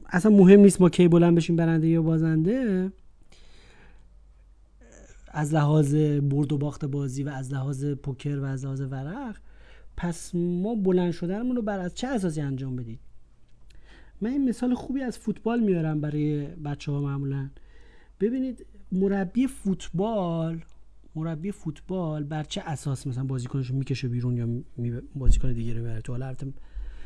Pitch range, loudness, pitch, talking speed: 135-185 Hz, -25 LUFS, 155 Hz, 150 wpm